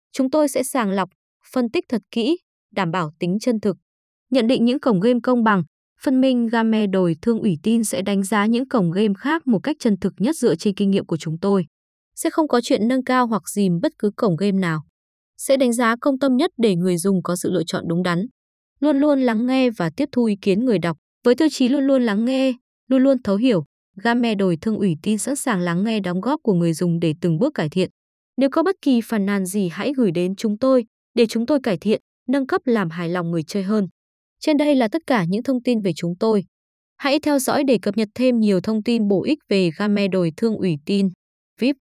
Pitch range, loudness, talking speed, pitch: 190-260 Hz, -20 LUFS, 245 wpm, 220 Hz